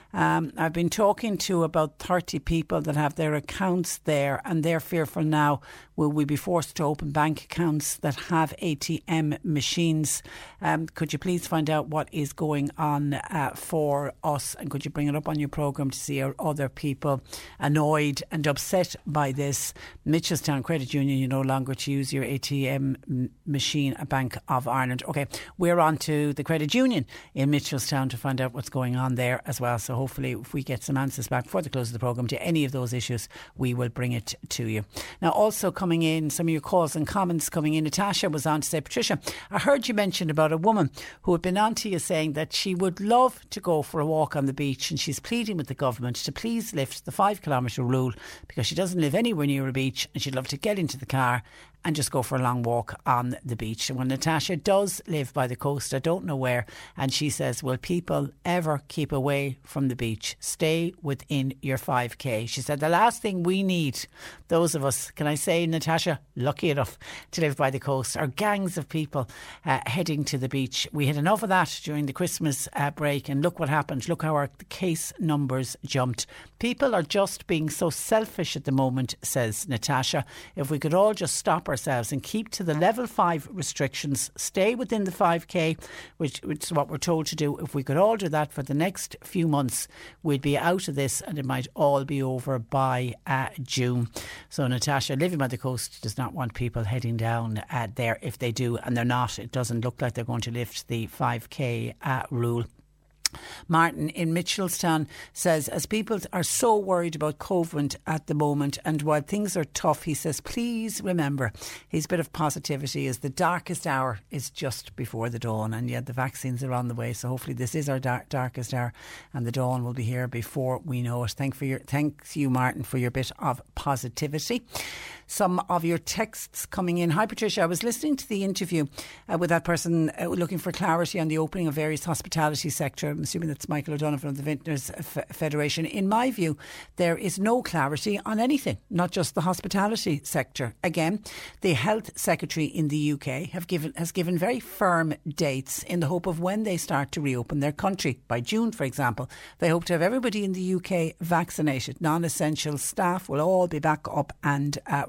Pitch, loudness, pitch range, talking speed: 150 Hz, -27 LUFS, 130-170 Hz, 210 wpm